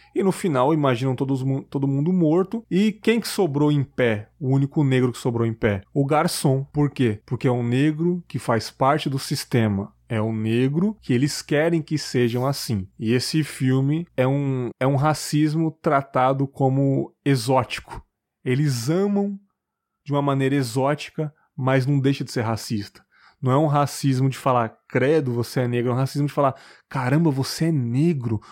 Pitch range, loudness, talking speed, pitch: 125-155 Hz, -22 LUFS, 175 wpm, 140 Hz